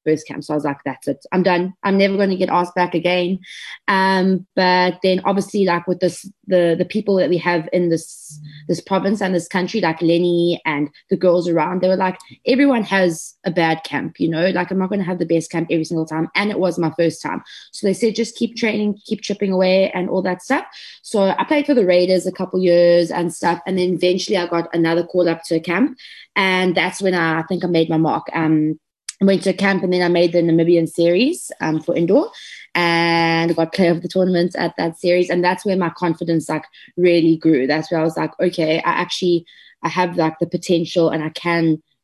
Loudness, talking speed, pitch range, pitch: -18 LUFS, 235 wpm, 165-185 Hz, 175 Hz